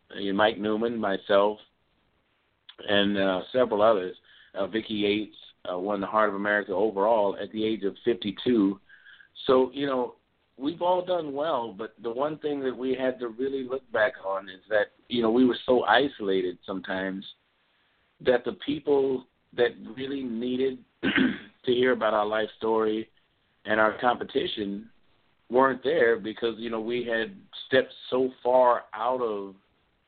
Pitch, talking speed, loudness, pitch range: 110 Hz, 155 wpm, -27 LUFS, 100-125 Hz